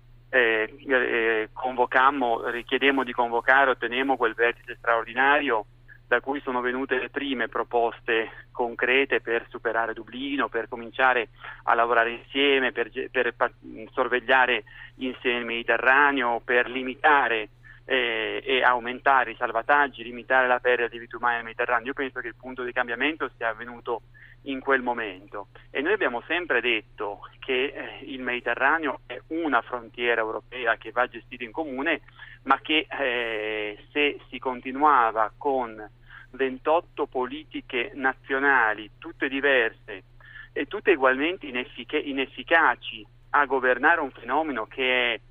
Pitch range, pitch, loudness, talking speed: 115-135 Hz, 125 Hz, -24 LUFS, 130 wpm